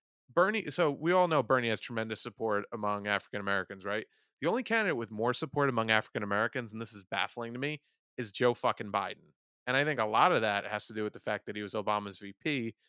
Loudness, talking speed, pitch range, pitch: -32 LUFS, 235 wpm, 105-130 Hz, 115 Hz